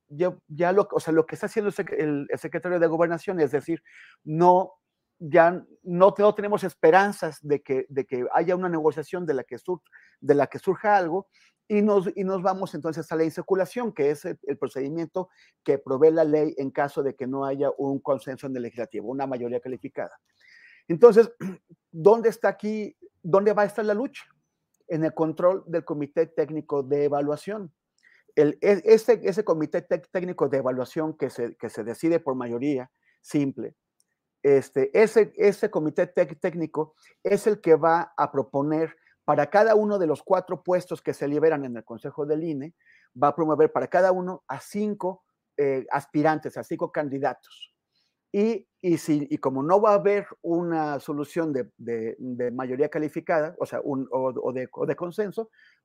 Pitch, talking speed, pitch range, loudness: 165 Hz, 180 wpm, 145-195 Hz, -25 LUFS